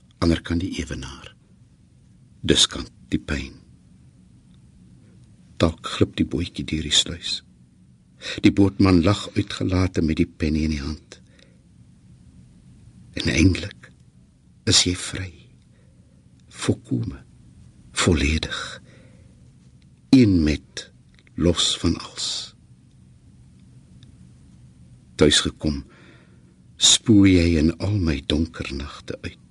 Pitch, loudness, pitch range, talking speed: 75 Hz, -21 LUFS, 60-90 Hz, 95 wpm